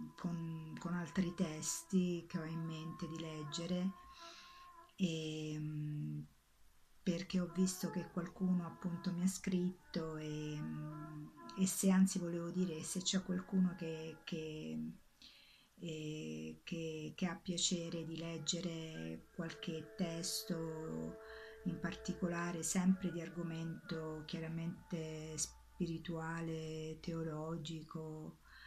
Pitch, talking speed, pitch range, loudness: 165 Hz, 100 wpm, 155-180 Hz, -41 LUFS